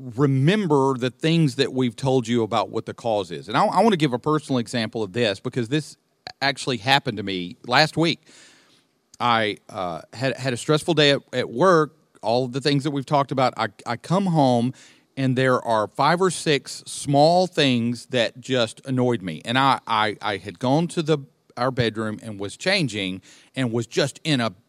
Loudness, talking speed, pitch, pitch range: -22 LUFS, 200 wpm, 130 Hz, 120-150 Hz